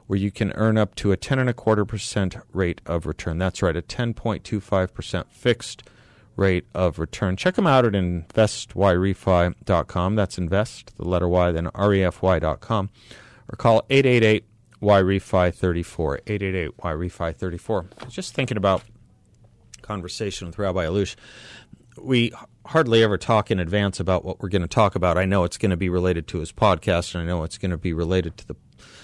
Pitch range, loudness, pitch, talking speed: 90-110 Hz, -23 LUFS, 100 Hz, 170 wpm